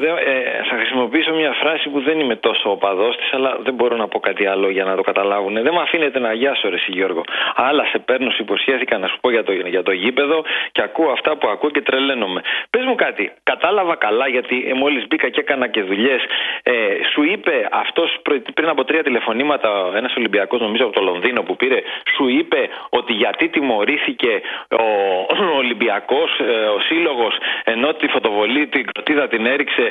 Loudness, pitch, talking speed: -17 LUFS, 265 Hz, 200 wpm